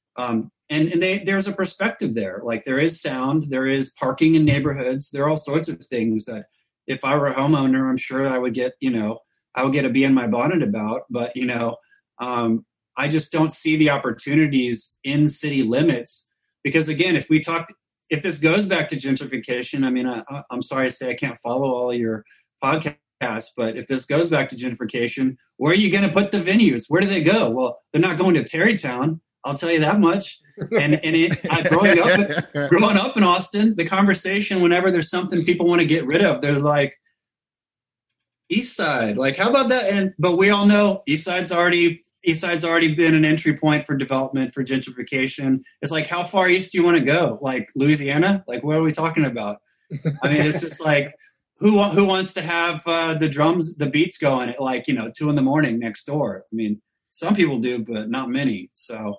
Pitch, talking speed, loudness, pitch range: 150 Hz, 215 wpm, -20 LUFS, 130-175 Hz